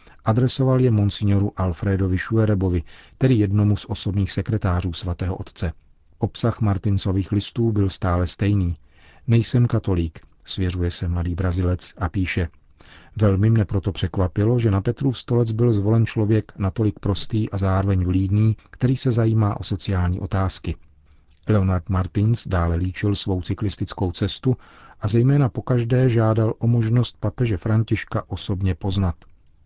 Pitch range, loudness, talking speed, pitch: 90-110 Hz, -22 LUFS, 135 wpm, 100 Hz